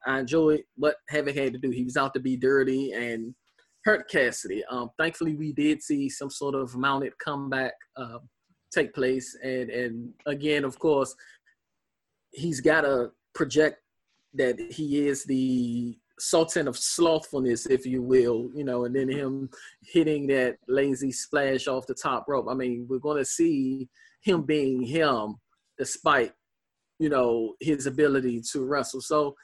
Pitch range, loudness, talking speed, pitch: 125-150 Hz, -27 LUFS, 160 wpm, 135 Hz